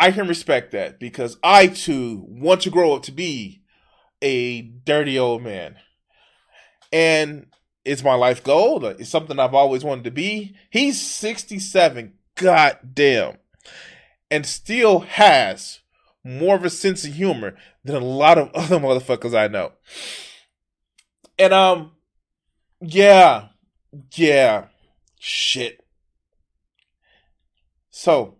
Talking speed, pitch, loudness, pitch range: 115 wpm, 150 Hz, -18 LUFS, 125-190 Hz